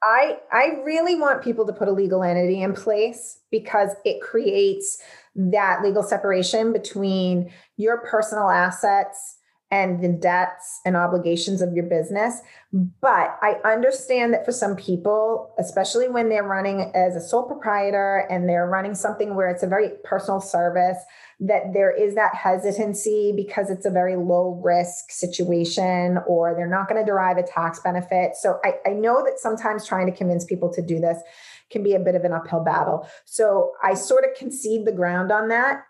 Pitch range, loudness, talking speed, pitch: 180-220 Hz, -22 LUFS, 175 wpm, 195 Hz